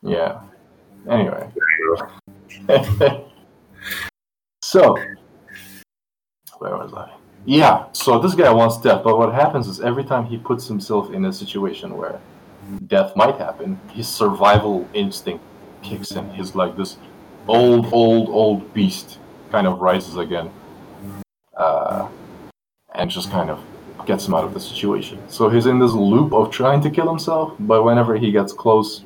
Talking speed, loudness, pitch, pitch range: 145 wpm, -18 LUFS, 115 Hz, 100-140 Hz